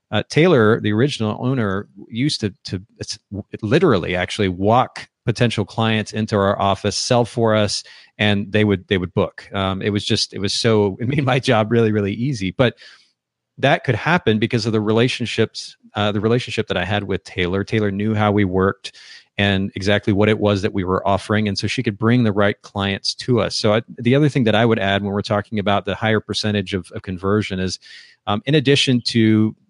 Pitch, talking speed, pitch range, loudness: 105 Hz, 210 wpm, 100-115 Hz, -19 LUFS